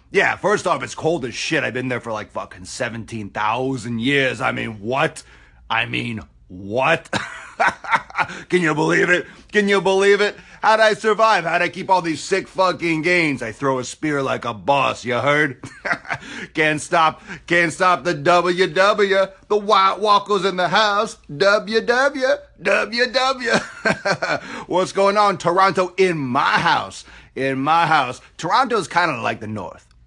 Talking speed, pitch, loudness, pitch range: 160 wpm, 175 Hz, -19 LUFS, 130-195 Hz